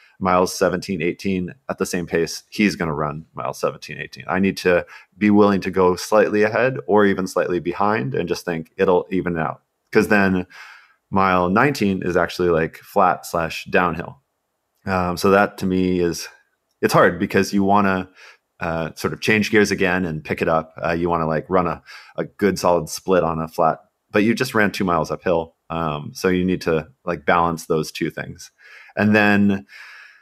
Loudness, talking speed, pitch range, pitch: -20 LUFS, 195 wpm, 85-100 Hz, 90 Hz